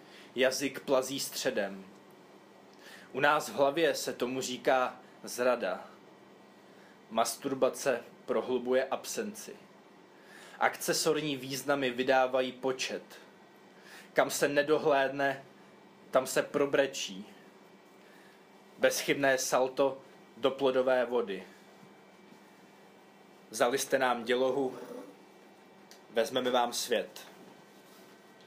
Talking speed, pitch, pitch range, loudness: 75 wpm, 130 Hz, 125-135 Hz, -31 LUFS